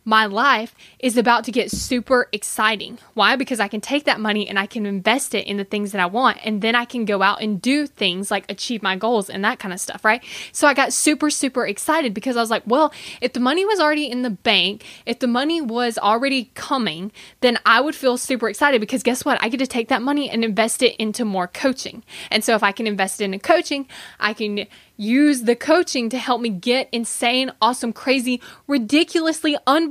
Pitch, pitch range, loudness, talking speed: 240 Hz, 215-265 Hz, -19 LUFS, 230 wpm